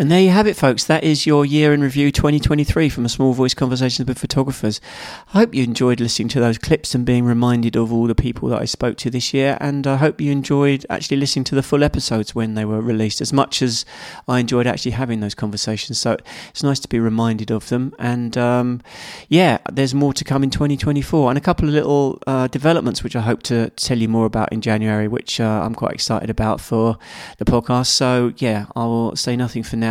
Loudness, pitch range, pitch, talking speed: -18 LUFS, 115-140 Hz, 125 Hz, 235 wpm